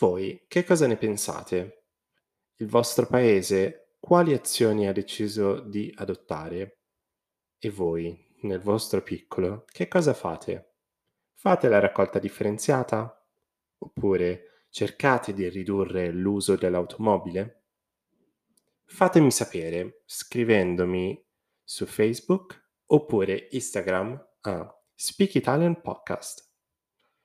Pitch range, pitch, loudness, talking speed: 95-125 Hz, 105 Hz, -26 LUFS, 95 wpm